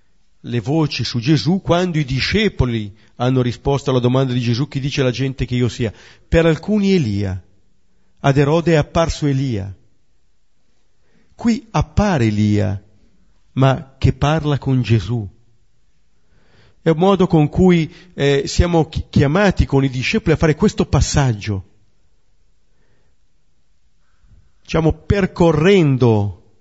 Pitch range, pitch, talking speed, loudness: 105-155 Hz, 130 Hz, 120 wpm, -17 LUFS